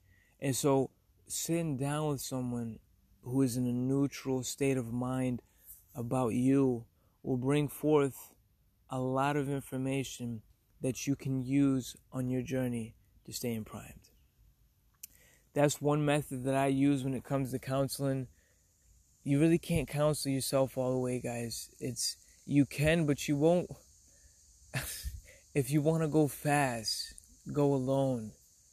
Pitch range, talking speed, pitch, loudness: 115-140 Hz, 140 wpm, 130 Hz, -33 LUFS